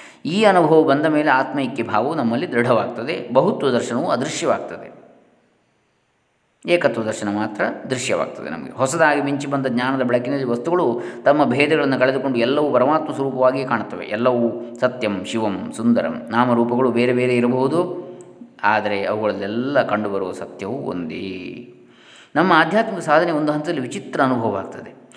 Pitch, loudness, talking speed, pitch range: 130 Hz, -19 LUFS, 120 wpm, 120-150 Hz